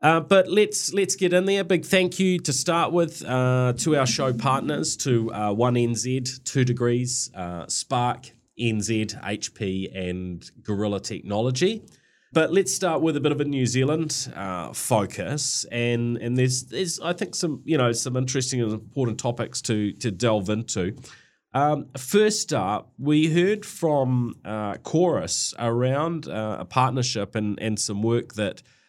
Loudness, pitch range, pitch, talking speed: -24 LUFS, 110-160 Hz, 125 Hz, 160 wpm